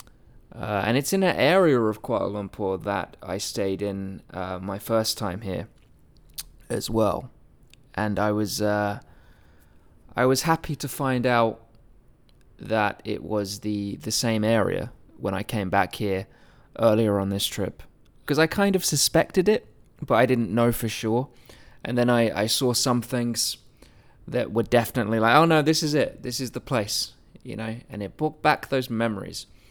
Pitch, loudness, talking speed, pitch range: 115 Hz, -24 LUFS, 175 wpm, 105-130 Hz